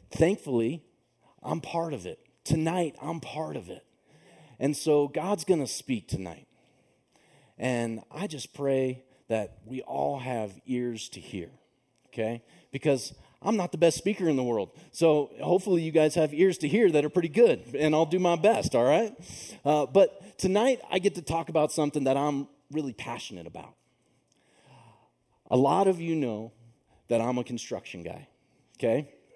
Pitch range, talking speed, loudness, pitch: 130-175 Hz, 165 wpm, -28 LUFS, 150 Hz